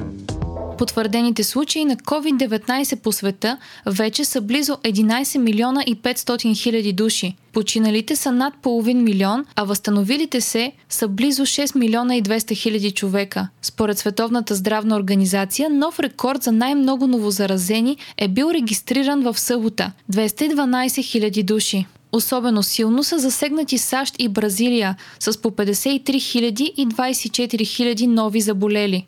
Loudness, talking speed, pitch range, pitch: -19 LUFS, 130 wpm, 210-260 Hz, 230 Hz